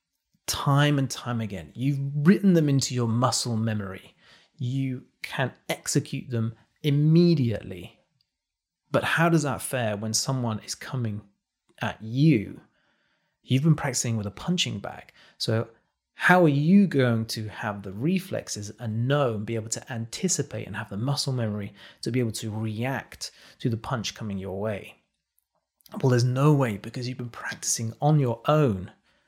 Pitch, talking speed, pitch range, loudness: 120 Hz, 160 wpm, 110-140 Hz, -26 LUFS